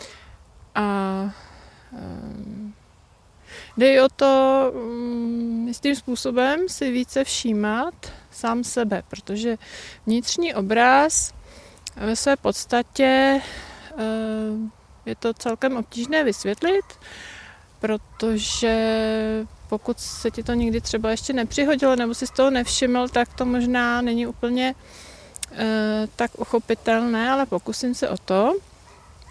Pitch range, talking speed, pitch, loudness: 220-260 Hz, 100 wpm, 235 Hz, -22 LUFS